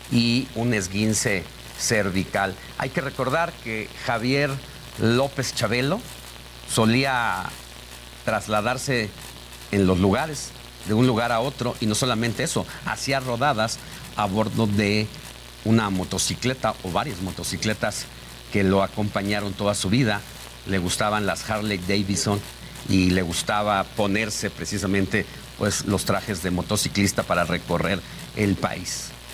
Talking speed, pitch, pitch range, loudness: 125 wpm, 105 Hz, 95-115 Hz, -24 LUFS